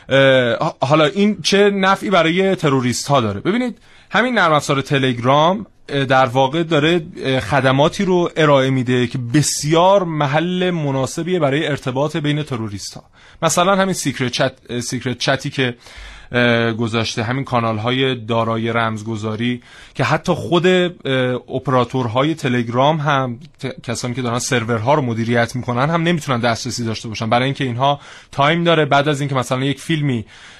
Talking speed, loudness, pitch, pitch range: 140 wpm, -17 LUFS, 135 Hz, 125-155 Hz